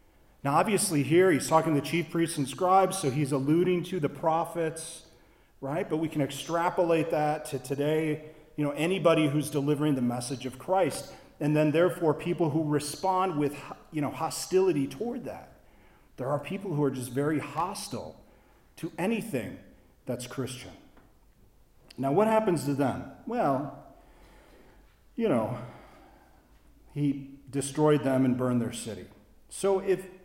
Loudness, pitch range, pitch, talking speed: -28 LUFS, 135-170 Hz, 150 Hz, 150 wpm